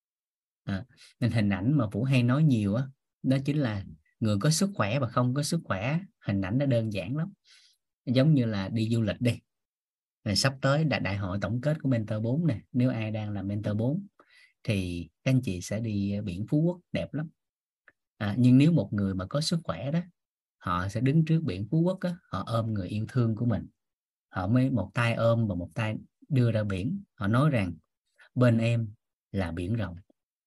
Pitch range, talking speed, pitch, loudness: 105-145 Hz, 215 wpm, 120 Hz, -28 LUFS